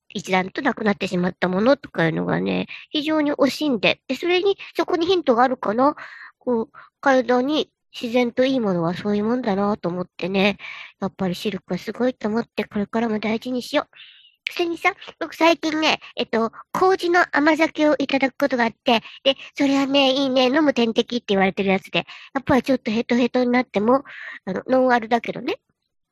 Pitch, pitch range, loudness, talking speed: 250 Hz, 205-285 Hz, -21 LUFS, 395 characters per minute